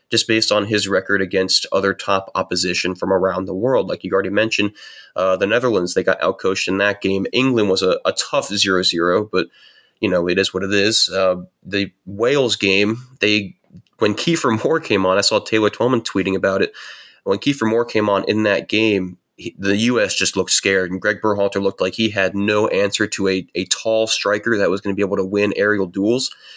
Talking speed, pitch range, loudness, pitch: 210 wpm, 95-110 Hz, -18 LUFS, 100 Hz